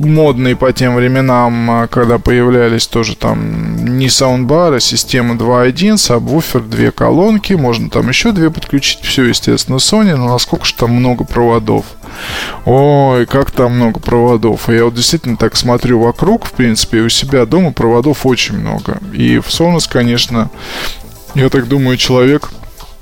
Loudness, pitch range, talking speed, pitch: -11 LUFS, 115-140 Hz, 155 wpm, 125 Hz